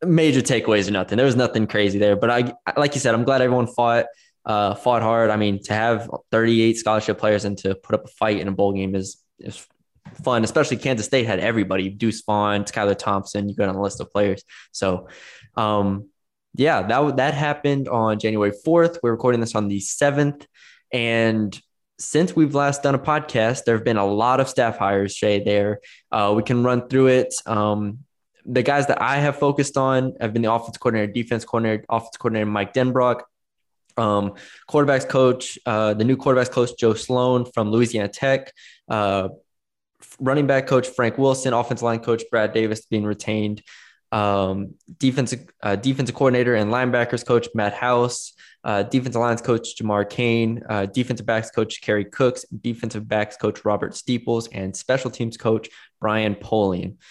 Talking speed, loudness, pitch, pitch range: 185 wpm, -21 LUFS, 115 Hz, 105-130 Hz